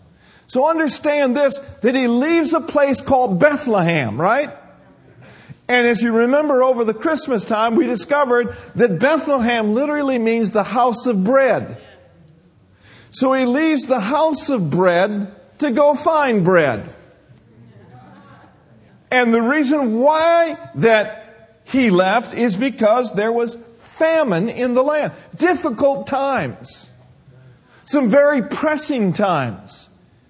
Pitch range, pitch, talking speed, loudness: 220-290 Hz, 255 Hz, 120 wpm, -17 LUFS